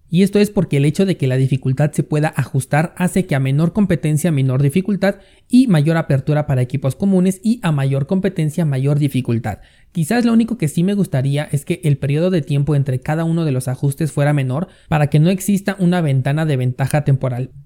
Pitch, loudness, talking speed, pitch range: 150 Hz, -17 LUFS, 210 wpm, 140-180 Hz